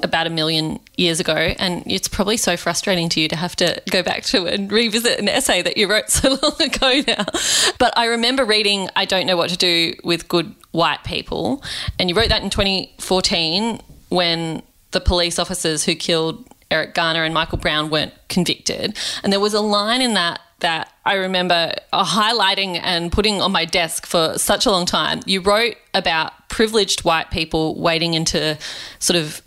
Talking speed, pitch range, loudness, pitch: 190 wpm, 165-210 Hz, -18 LUFS, 180 Hz